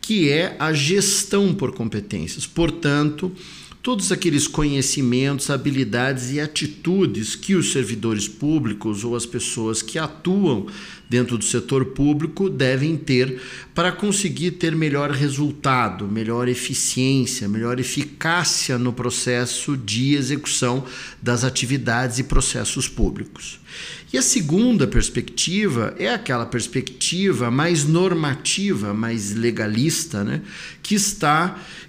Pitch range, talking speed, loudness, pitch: 125-165 Hz, 115 wpm, -21 LUFS, 140 Hz